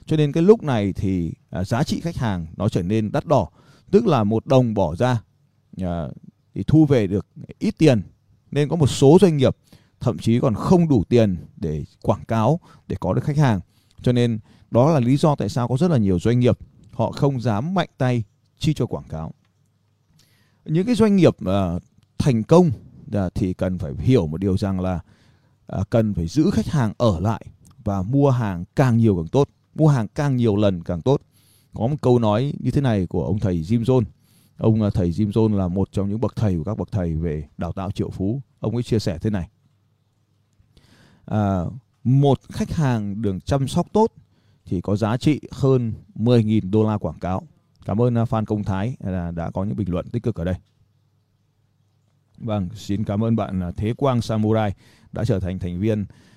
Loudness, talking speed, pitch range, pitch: -21 LUFS, 200 wpm, 100-130 Hz, 110 Hz